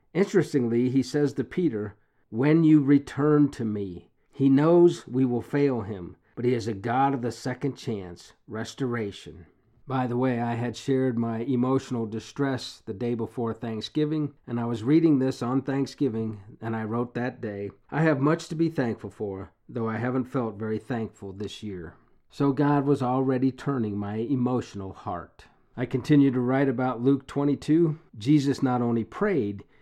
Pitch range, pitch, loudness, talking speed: 110-140 Hz, 125 Hz, -26 LUFS, 170 wpm